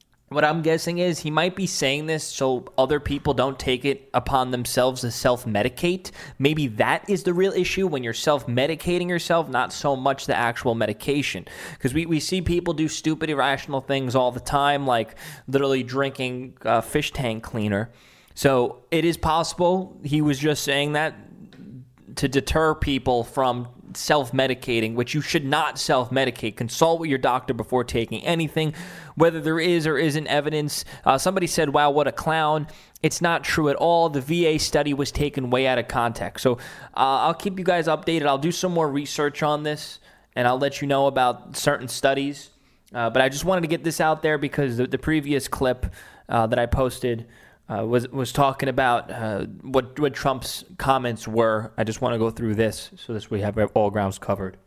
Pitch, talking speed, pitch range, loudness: 140 Hz, 195 wpm, 125-155 Hz, -23 LUFS